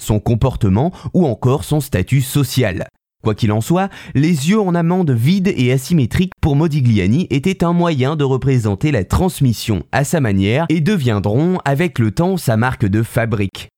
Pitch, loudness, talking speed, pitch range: 130 Hz, -16 LUFS, 170 wpm, 110-170 Hz